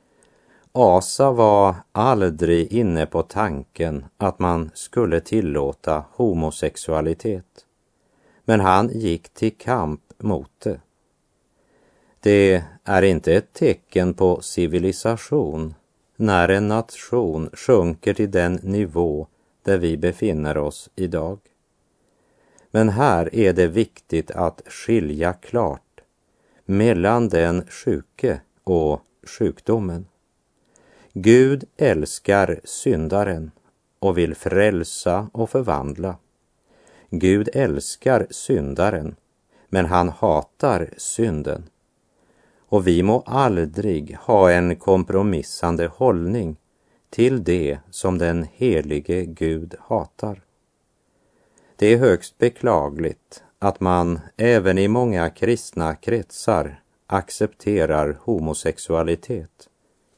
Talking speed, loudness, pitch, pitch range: 95 wpm, -20 LUFS, 90 Hz, 85-105 Hz